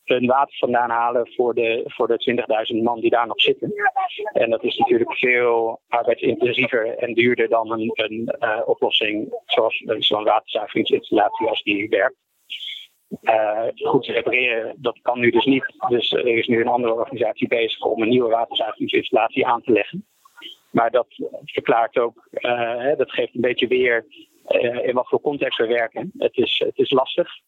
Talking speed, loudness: 175 wpm, -20 LUFS